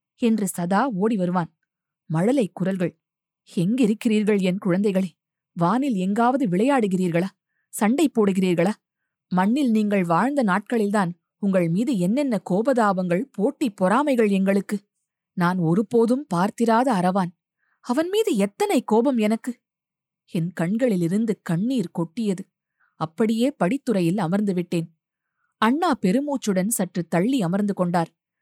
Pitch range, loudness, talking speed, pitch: 175-230 Hz, -22 LUFS, 100 wpm, 200 Hz